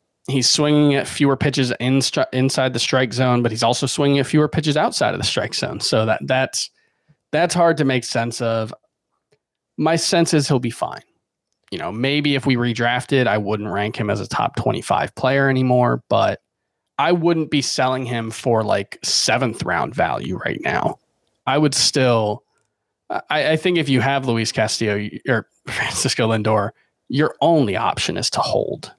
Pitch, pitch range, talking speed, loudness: 130 Hz, 115-145 Hz, 180 wpm, -19 LUFS